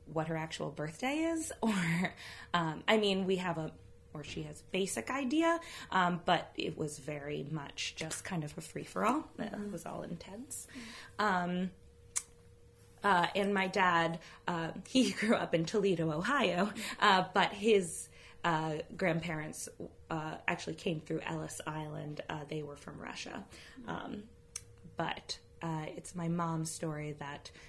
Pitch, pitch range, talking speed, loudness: 170 Hz, 155-195 Hz, 145 wpm, -35 LUFS